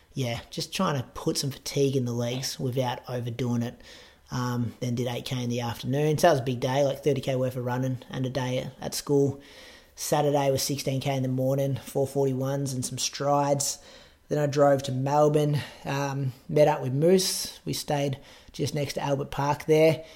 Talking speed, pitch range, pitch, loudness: 190 wpm, 130-145 Hz, 140 Hz, -27 LUFS